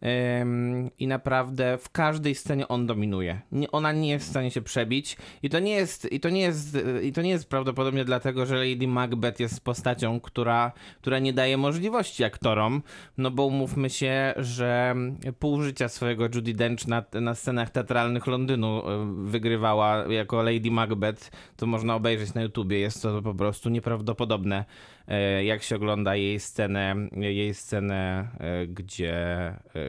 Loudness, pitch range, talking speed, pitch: -27 LUFS, 105-130 Hz, 155 wpm, 120 Hz